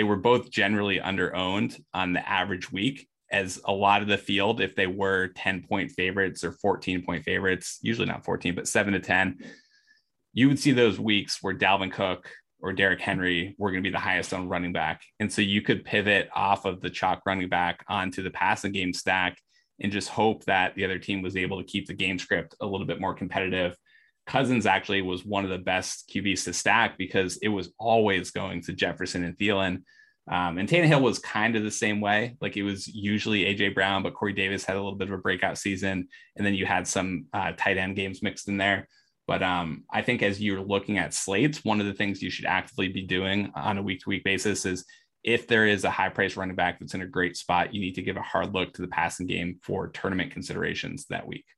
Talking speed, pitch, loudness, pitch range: 230 wpm, 95 Hz, -27 LUFS, 90-105 Hz